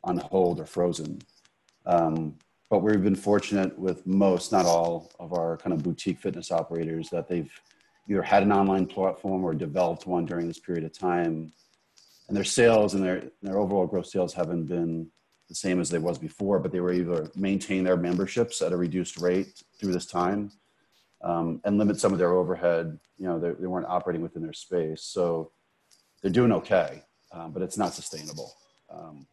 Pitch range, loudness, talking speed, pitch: 85-95 Hz, -27 LUFS, 190 wpm, 90 Hz